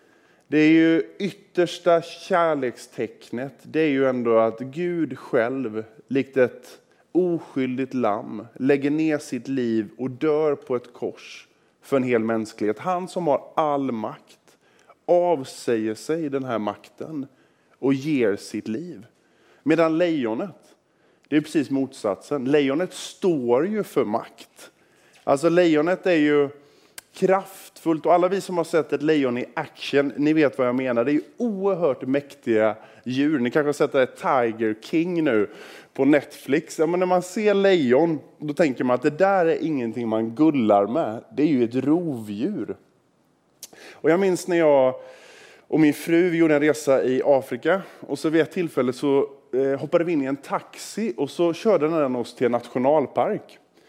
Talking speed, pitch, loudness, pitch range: 160 wpm, 150 Hz, -23 LUFS, 130-170 Hz